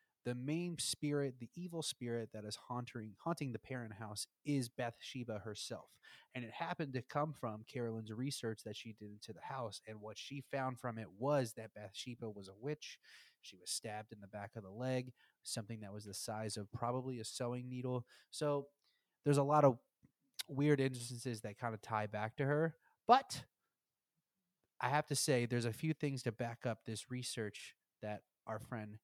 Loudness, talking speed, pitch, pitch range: -41 LUFS, 190 wpm, 120 Hz, 110-140 Hz